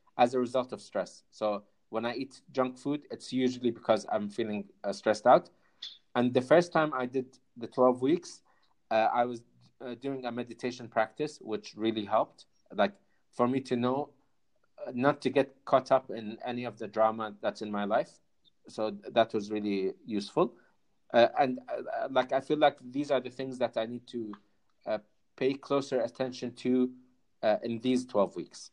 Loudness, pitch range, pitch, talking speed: -31 LUFS, 110-130 Hz, 125 Hz, 190 wpm